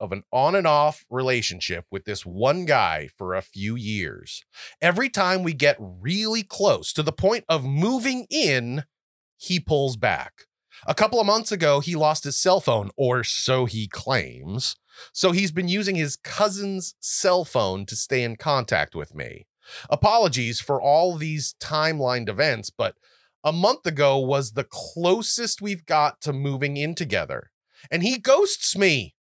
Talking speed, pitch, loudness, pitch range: 165 wpm, 150 Hz, -23 LUFS, 125-185 Hz